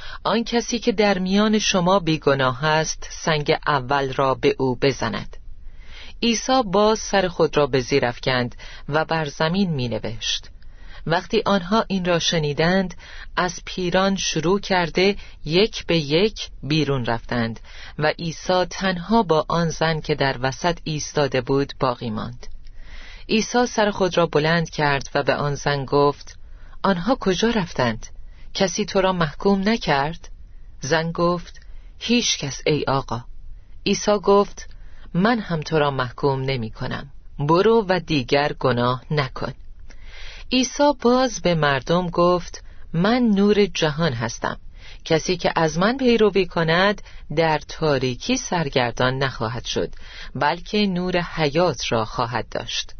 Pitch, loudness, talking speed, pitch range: 160 Hz, -21 LUFS, 135 wpm, 130-195 Hz